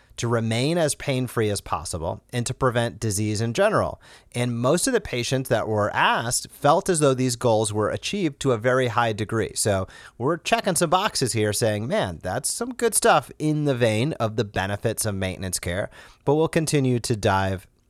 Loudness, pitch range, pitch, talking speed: -23 LUFS, 110-140 Hz, 120 Hz, 200 wpm